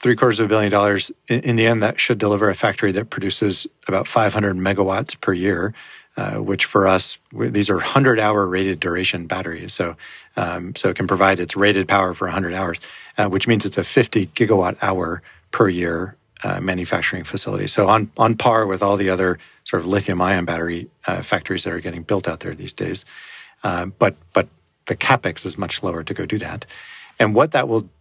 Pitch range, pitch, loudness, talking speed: 95-110 Hz, 100 Hz, -20 LUFS, 200 wpm